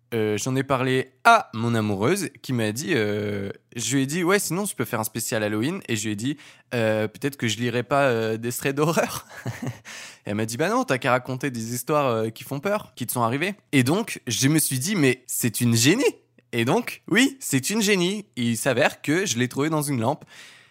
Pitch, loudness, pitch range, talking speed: 130 Hz, -23 LUFS, 115-150 Hz, 240 wpm